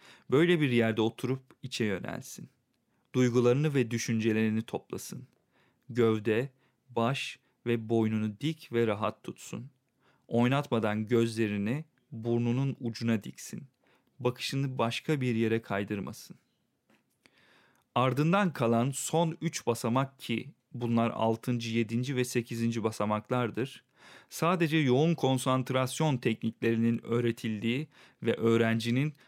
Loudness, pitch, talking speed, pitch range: -30 LUFS, 120 Hz, 95 wpm, 115-130 Hz